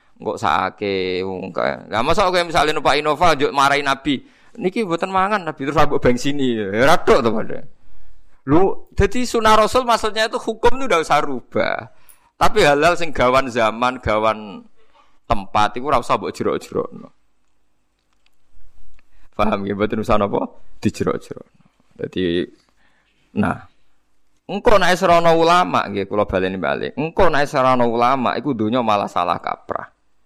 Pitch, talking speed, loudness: 140 Hz, 150 wpm, -18 LUFS